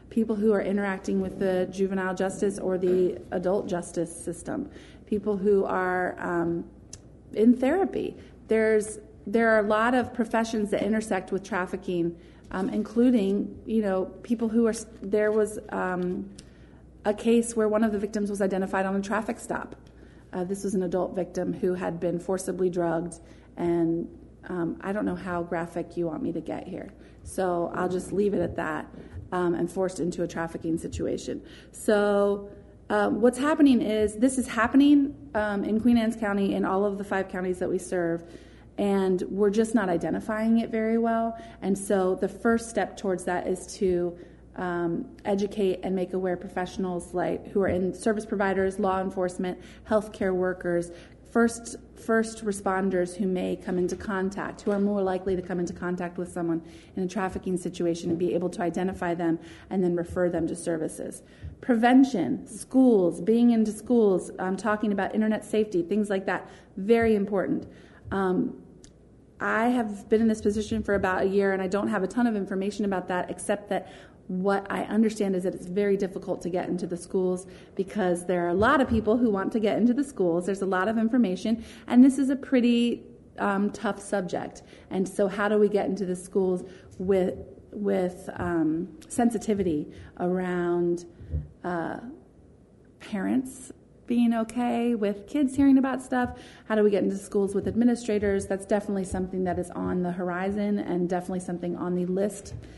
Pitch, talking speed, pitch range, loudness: 195 Hz, 175 wpm, 180-215 Hz, -27 LUFS